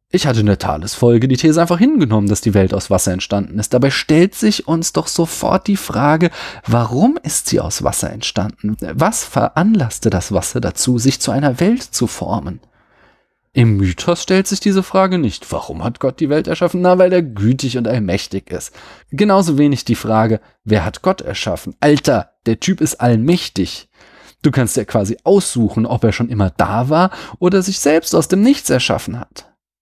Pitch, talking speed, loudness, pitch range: 135 Hz, 190 wpm, -15 LUFS, 110-175 Hz